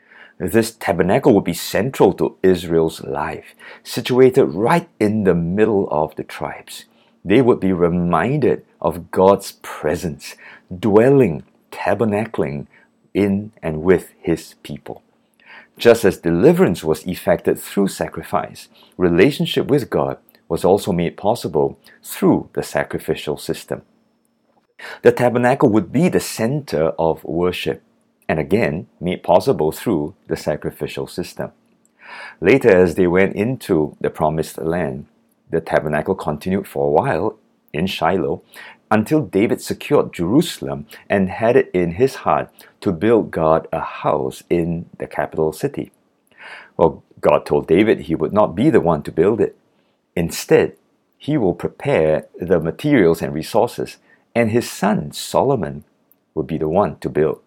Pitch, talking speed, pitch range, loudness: 95 Hz, 135 wpm, 80-115 Hz, -18 LUFS